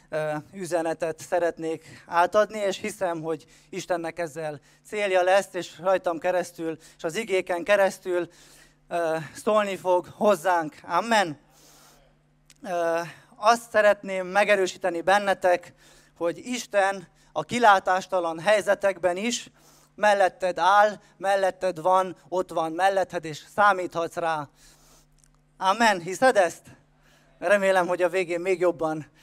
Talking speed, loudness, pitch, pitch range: 105 wpm, -25 LUFS, 180 Hz, 165-195 Hz